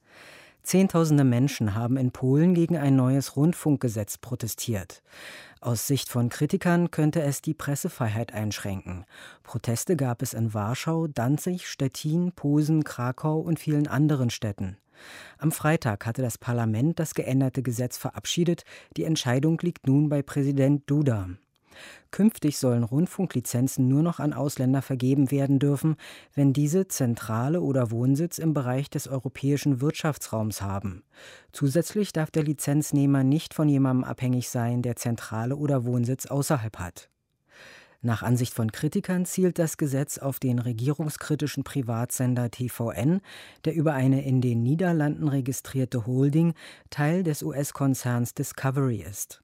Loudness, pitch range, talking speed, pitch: -26 LUFS, 125-155 Hz, 130 wpm, 135 Hz